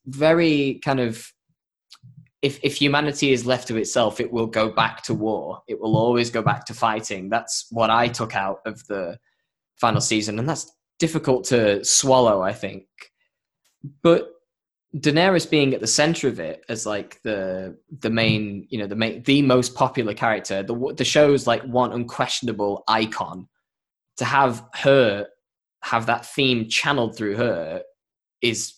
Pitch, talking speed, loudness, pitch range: 125 Hz, 160 wpm, -21 LUFS, 110-140 Hz